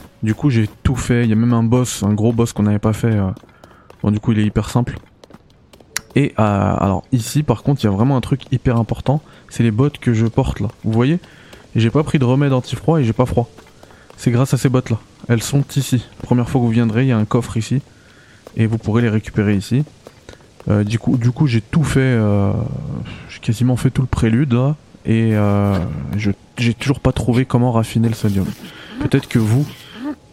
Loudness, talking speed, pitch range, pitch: -17 LUFS, 230 wpm, 110-130 Hz, 120 Hz